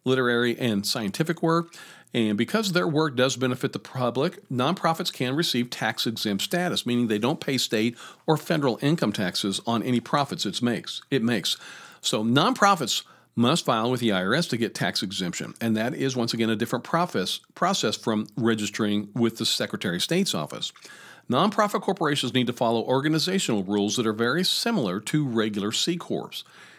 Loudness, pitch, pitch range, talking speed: -25 LUFS, 130 Hz, 115-170 Hz, 170 wpm